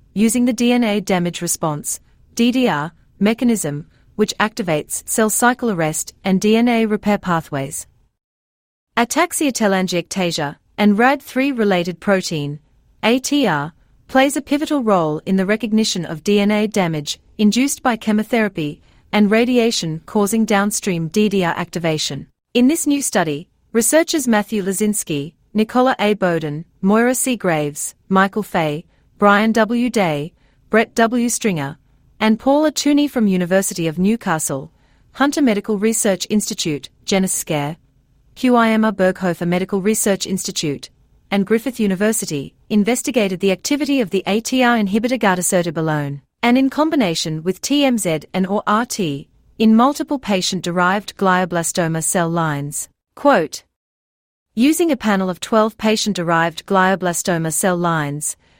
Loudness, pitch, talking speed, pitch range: -18 LUFS, 200 Hz, 120 wpm, 170-230 Hz